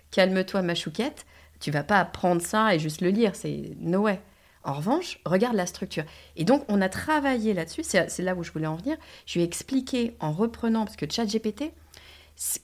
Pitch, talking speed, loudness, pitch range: 195 Hz, 210 wpm, -27 LUFS, 170-230 Hz